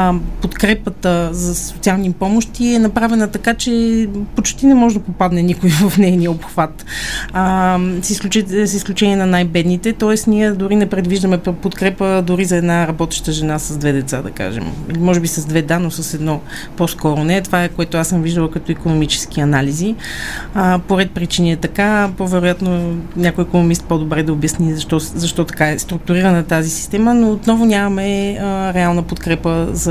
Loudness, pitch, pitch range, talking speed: -15 LUFS, 180 Hz, 165-200 Hz, 165 wpm